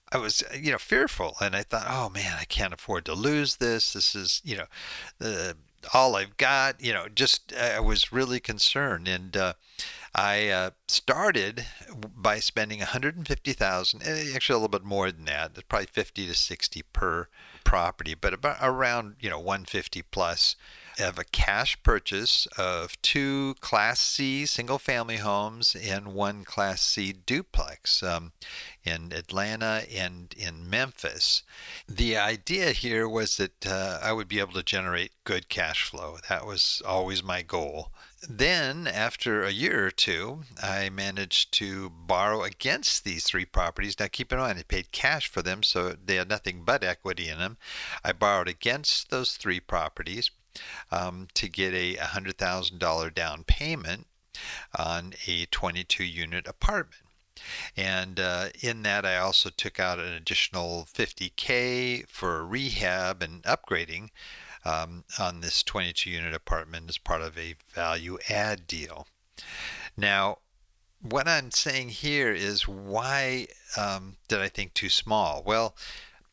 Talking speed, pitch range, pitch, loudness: 155 wpm, 90-115 Hz, 100 Hz, -27 LUFS